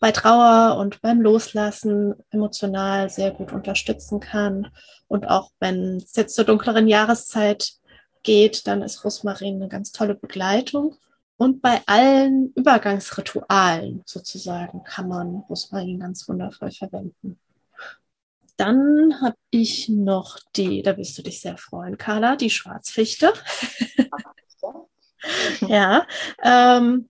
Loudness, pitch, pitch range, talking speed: -20 LUFS, 215 Hz, 195-240 Hz, 115 wpm